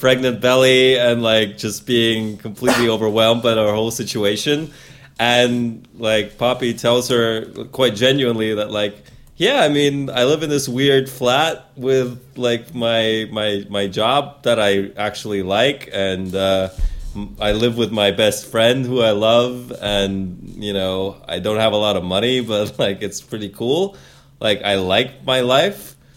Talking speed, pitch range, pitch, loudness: 165 wpm, 105-125 Hz, 115 Hz, -17 LUFS